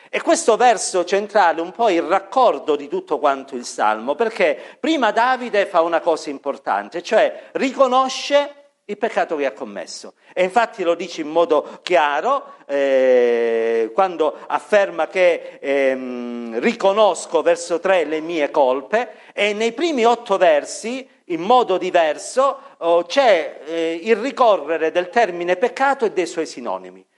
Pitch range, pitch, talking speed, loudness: 165-260 Hz, 200 Hz, 145 wpm, -19 LUFS